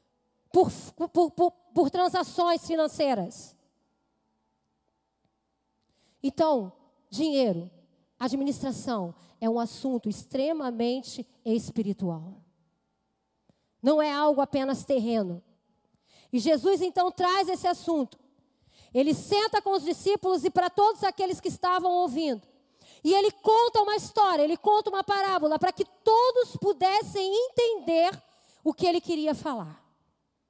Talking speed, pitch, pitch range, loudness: 110 wpm, 315 Hz, 255-370 Hz, -27 LUFS